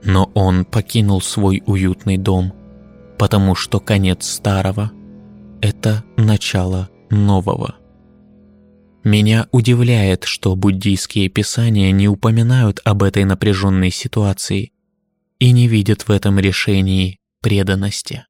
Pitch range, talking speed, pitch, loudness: 95-110 Hz, 100 wpm, 100 Hz, -16 LUFS